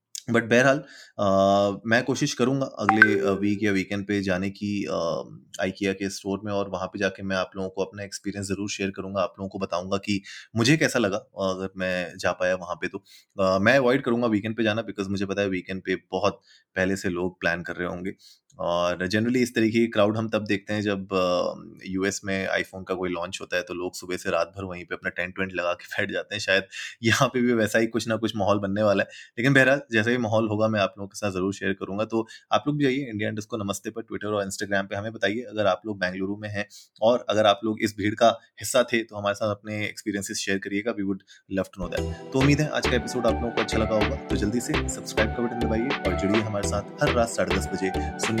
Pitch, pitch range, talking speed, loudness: 100 Hz, 95-110 Hz, 245 wpm, -25 LUFS